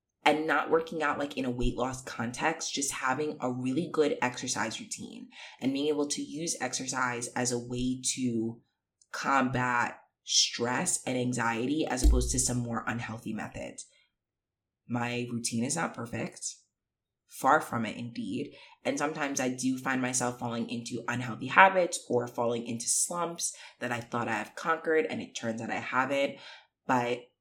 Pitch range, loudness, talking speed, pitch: 120-140 Hz, -30 LUFS, 160 wpm, 125 Hz